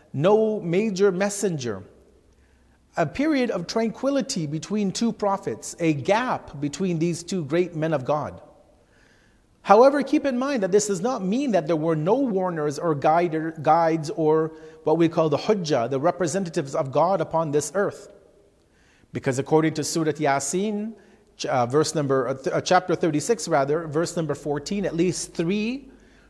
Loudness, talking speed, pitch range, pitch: -23 LUFS, 150 wpm, 155-200 Hz, 170 Hz